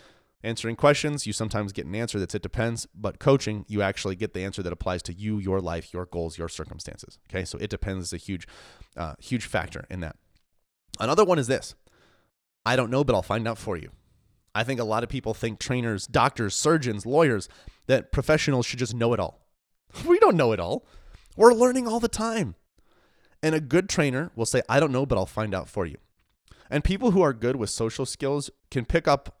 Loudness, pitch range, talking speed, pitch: -26 LUFS, 95-140 Hz, 215 wpm, 115 Hz